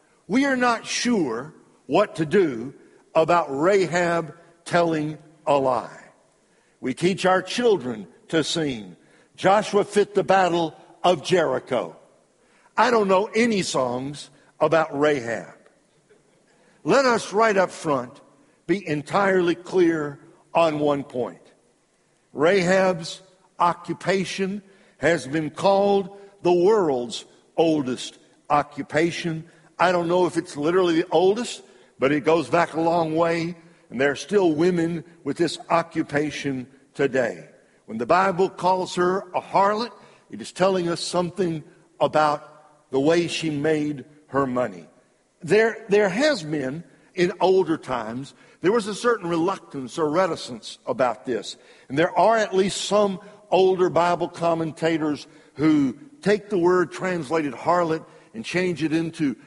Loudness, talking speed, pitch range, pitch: -22 LUFS, 130 wpm, 155-190 Hz, 170 Hz